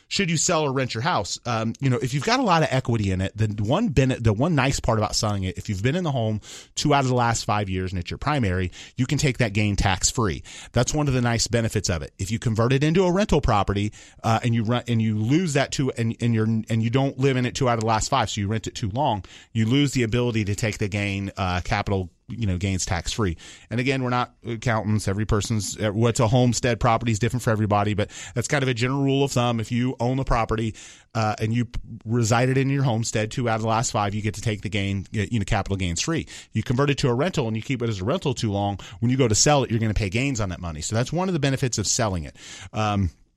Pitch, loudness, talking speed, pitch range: 115 Hz, -23 LUFS, 285 wpm, 105-130 Hz